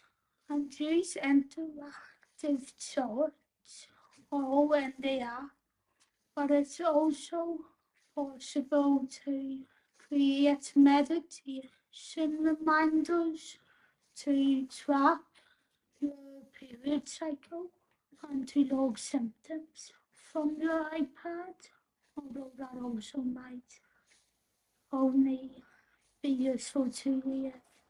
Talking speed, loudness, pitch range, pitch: 80 wpm, -32 LUFS, 270-310 Hz, 285 Hz